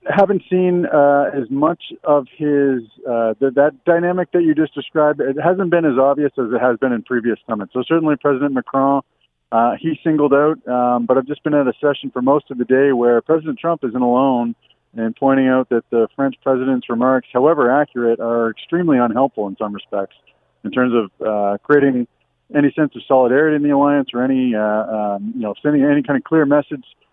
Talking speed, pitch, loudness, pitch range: 205 wpm, 135 Hz, -17 LUFS, 120-150 Hz